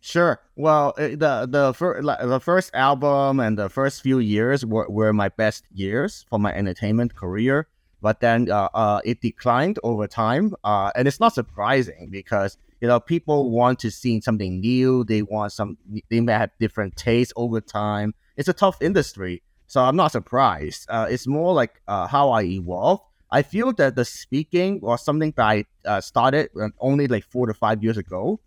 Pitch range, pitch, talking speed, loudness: 105-140 Hz, 120 Hz, 185 wpm, -22 LUFS